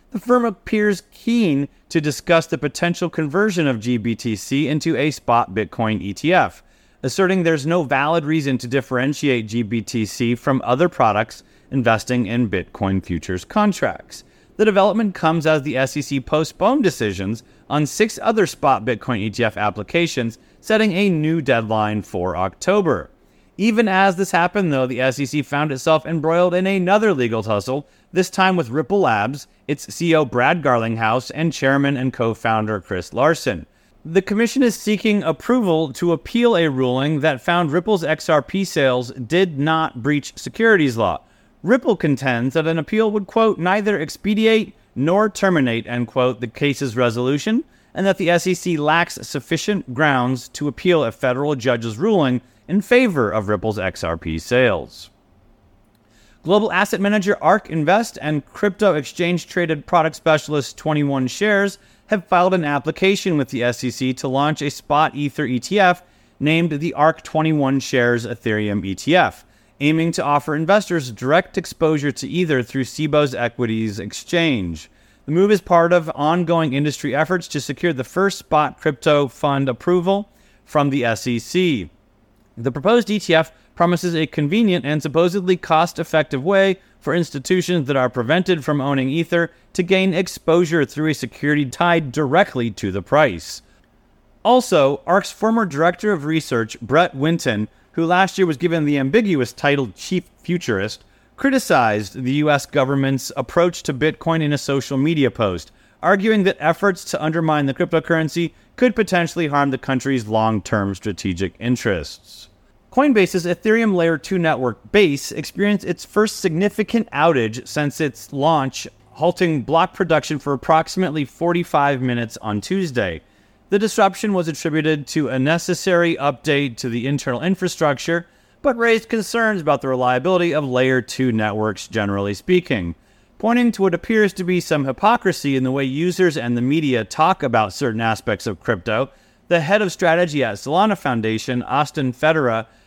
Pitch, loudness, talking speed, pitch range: 150 Hz, -19 LUFS, 150 wpm, 125-180 Hz